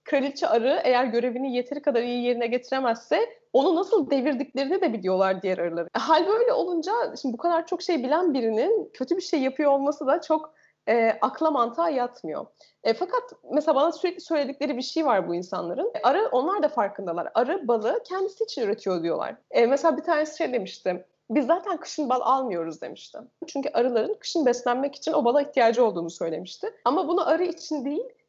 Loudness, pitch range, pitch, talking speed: -25 LUFS, 240-335 Hz, 285 Hz, 180 wpm